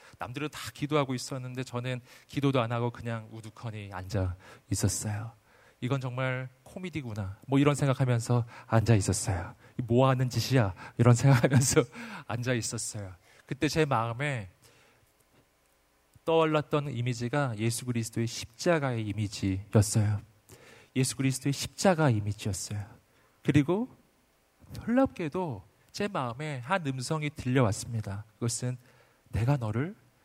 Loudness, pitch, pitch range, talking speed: -30 LUFS, 125 Hz, 110-140 Hz, 295 characters per minute